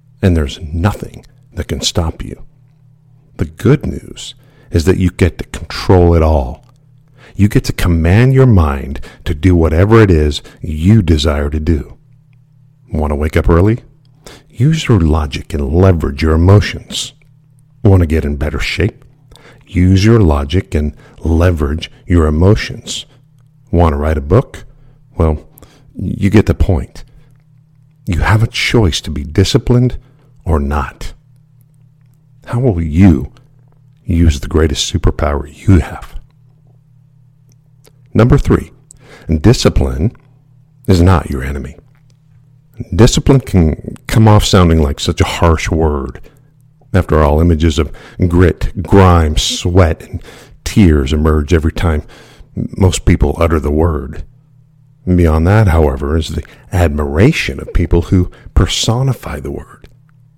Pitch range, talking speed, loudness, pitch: 80-135 Hz, 130 wpm, -13 LUFS, 95 Hz